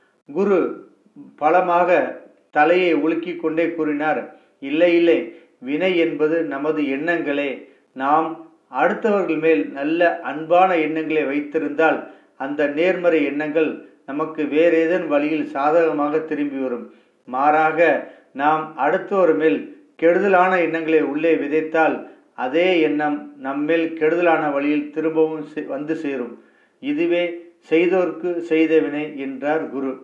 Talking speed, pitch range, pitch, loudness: 100 wpm, 150-170 Hz, 160 Hz, -20 LUFS